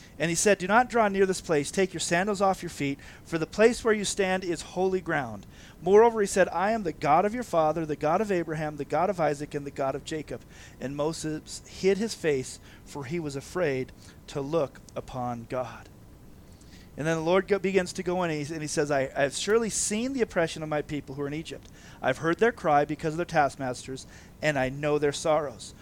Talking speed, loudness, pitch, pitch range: 230 wpm, -27 LUFS, 155 Hz, 130-185 Hz